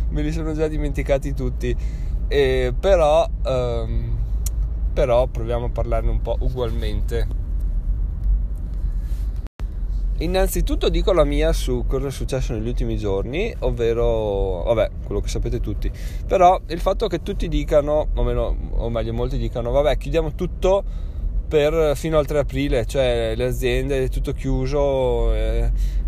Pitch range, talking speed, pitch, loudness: 110-145 Hz, 140 wpm, 120 Hz, -22 LUFS